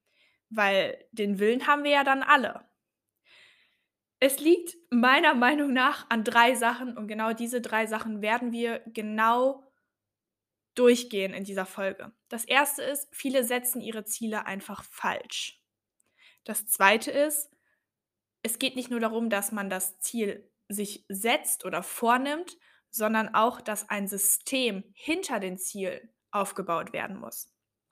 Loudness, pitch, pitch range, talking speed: -27 LUFS, 230 Hz, 210-260 Hz, 140 wpm